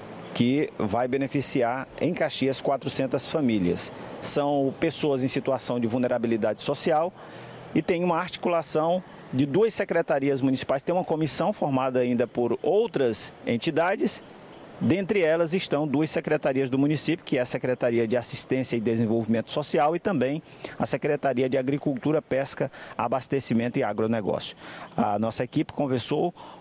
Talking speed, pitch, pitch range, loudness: 135 wpm, 135 Hz, 125-155 Hz, -25 LUFS